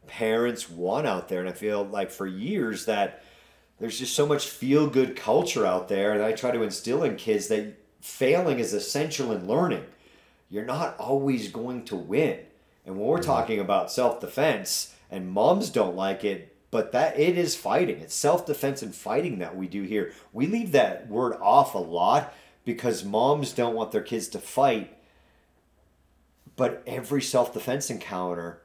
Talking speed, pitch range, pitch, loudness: 180 wpm, 95-135 Hz, 110 Hz, -26 LUFS